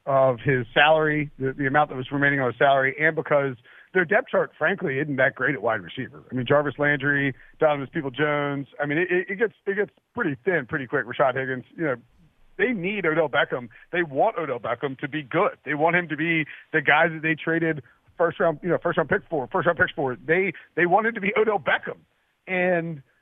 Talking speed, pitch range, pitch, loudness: 225 wpm, 140-170 Hz, 150 Hz, -23 LUFS